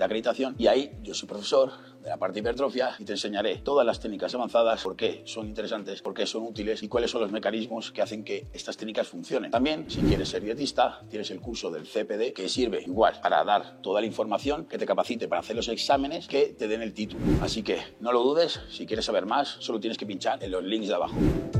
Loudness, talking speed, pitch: -28 LUFS, 240 wpm, 115 Hz